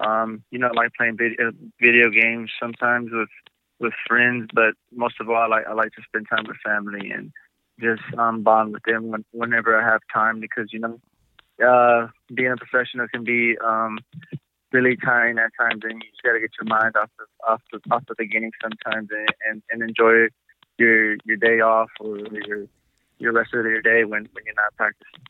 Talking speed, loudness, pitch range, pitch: 200 wpm, -20 LUFS, 110-120 Hz, 115 Hz